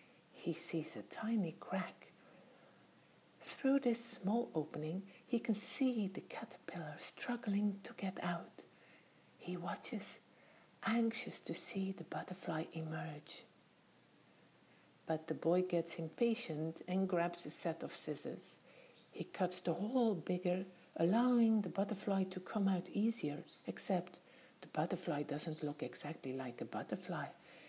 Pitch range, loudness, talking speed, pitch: 165-220 Hz, -39 LUFS, 125 wpm, 180 Hz